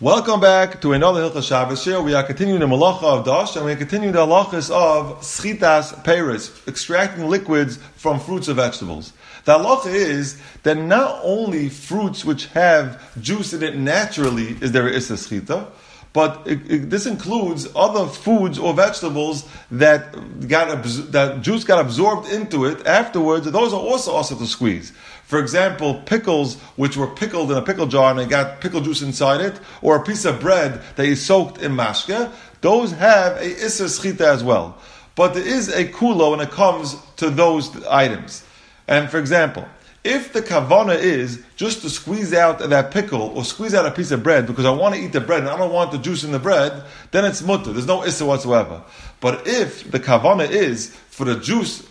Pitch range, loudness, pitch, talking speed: 140-195 Hz, -18 LUFS, 160 Hz, 195 wpm